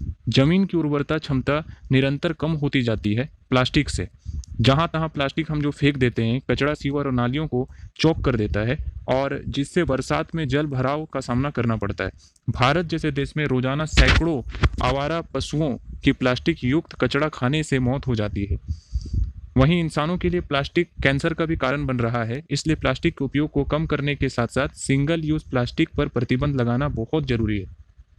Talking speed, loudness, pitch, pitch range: 185 wpm, -23 LUFS, 135 Hz, 120-150 Hz